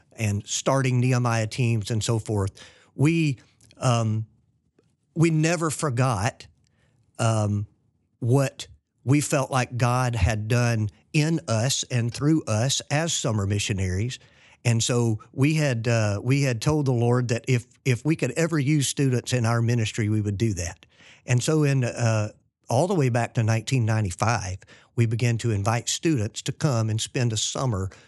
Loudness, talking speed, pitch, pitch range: -24 LUFS, 160 wpm, 120 Hz, 110-135 Hz